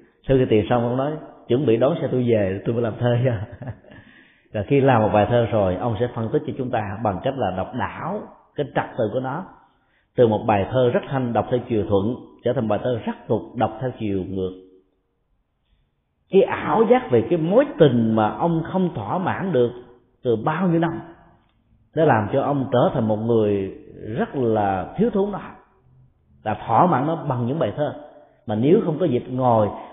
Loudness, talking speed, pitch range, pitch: -21 LUFS, 215 wpm, 110-140 Hz, 120 Hz